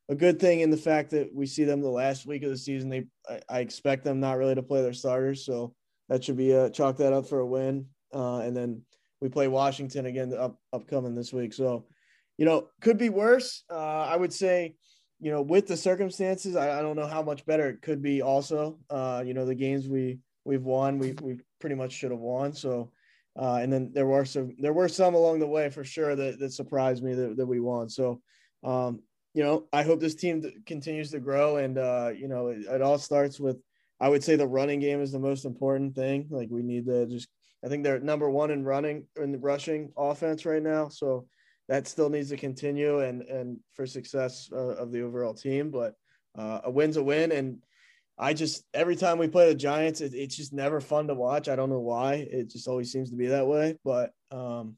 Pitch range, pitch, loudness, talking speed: 130-150 Hz, 135 Hz, -28 LUFS, 235 wpm